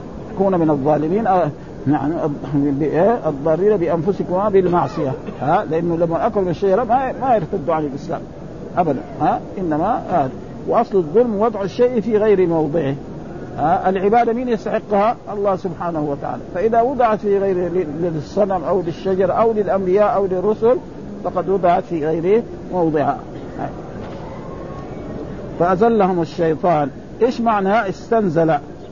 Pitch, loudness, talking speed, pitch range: 185 Hz, -18 LUFS, 120 wpm, 165-210 Hz